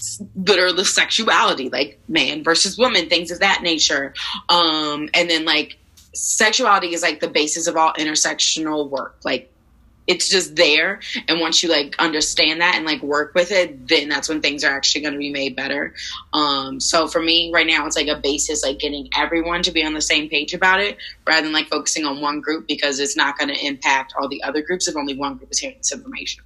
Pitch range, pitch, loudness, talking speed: 145-175 Hz, 155 Hz, -18 LUFS, 220 wpm